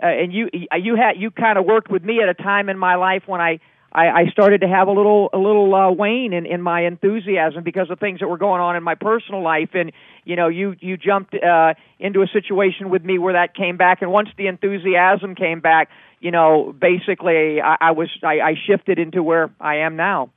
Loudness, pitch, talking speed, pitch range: -17 LUFS, 185 Hz, 240 wpm, 170-200 Hz